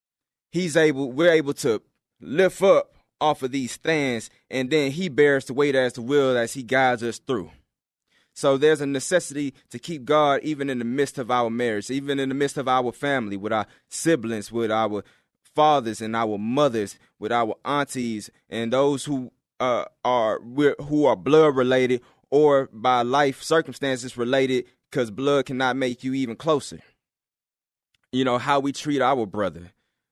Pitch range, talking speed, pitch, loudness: 120-145 Hz, 170 wpm, 135 Hz, -23 LUFS